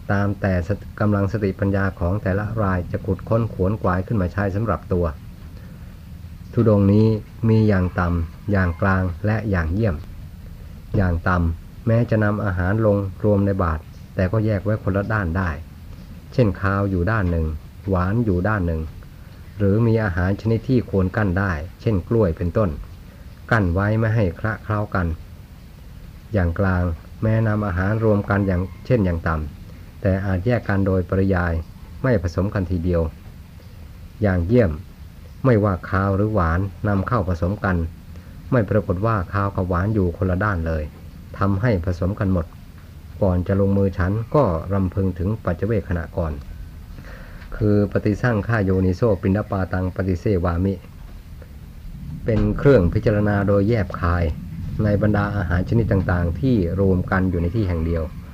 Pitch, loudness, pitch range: 95 Hz, -21 LUFS, 85-105 Hz